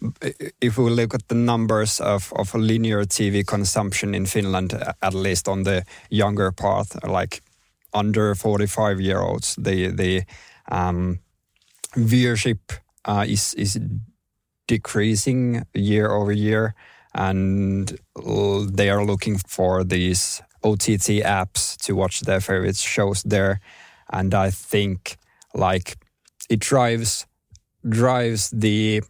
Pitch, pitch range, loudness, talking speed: 100 Hz, 95-110 Hz, -22 LUFS, 120 wpm